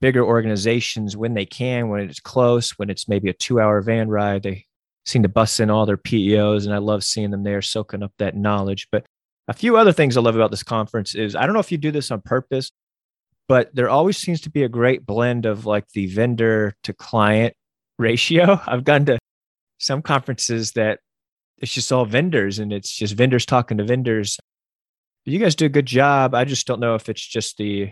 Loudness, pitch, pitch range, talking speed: -19 LUFS, 115 Hz, 105-130 Hz, 220 wpm